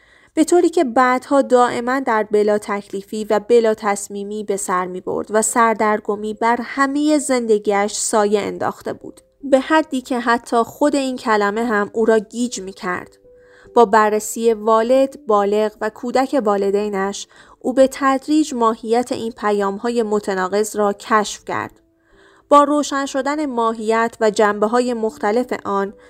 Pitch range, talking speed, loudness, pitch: 210-260 Hz, 145 wpm, -18 LUFS, 225 Hz